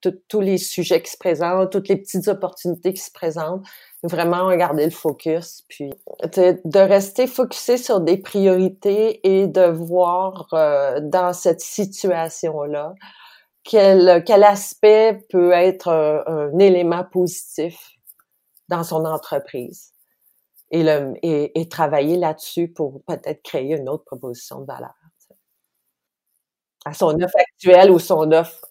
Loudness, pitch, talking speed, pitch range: -18 LUFS, 180 Hz, 140 wpm, 165-190 Hz